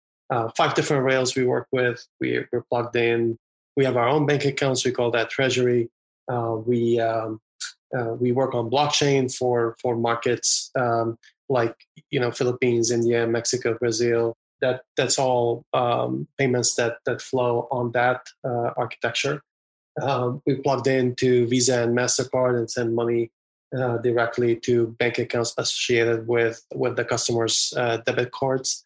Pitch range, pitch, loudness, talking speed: 115-130 Hz, 120 Hz, -23 LUFS, 155 wpm